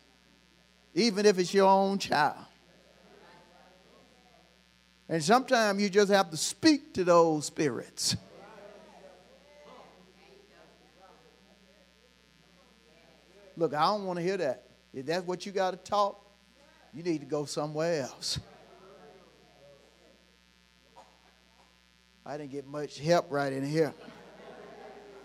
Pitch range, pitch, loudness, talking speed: 140-200 Hz, 175 Hz, -29 LUFS, 105 wpm